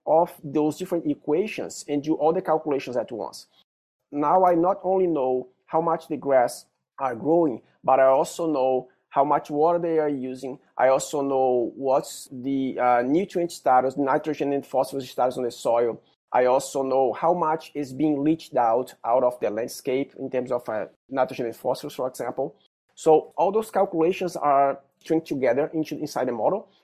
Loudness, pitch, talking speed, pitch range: -24 LUFS, 145 Hz, 180 wpm, 130-160 Hz